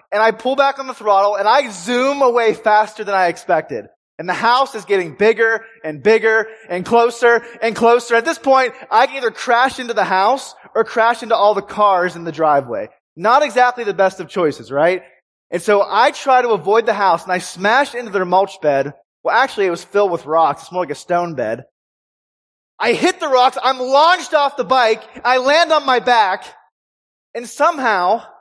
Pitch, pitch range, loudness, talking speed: 220 Hz, 190-255 Hz, -16 LUFS, 205 wpm